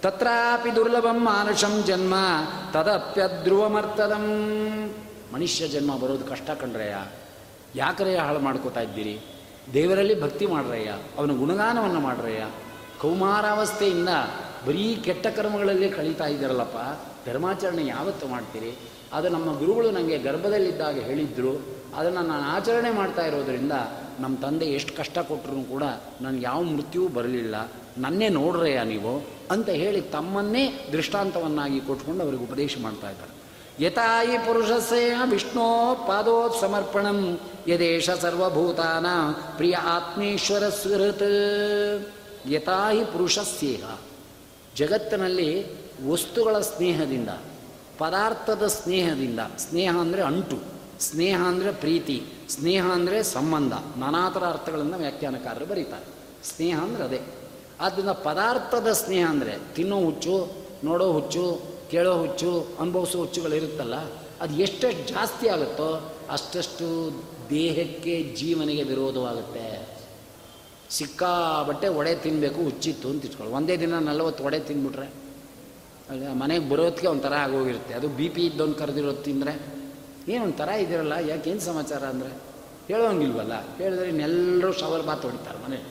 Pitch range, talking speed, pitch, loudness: 140-195 Hz, 105 wpm, 170 Hz, -25 LUFS